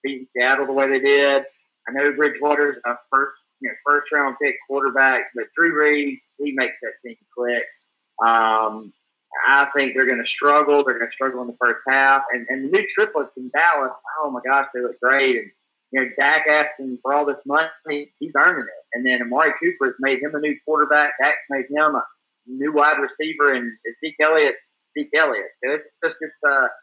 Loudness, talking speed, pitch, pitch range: -19 LUFS, 205 wpm, 140 Hz, 130-150 Hz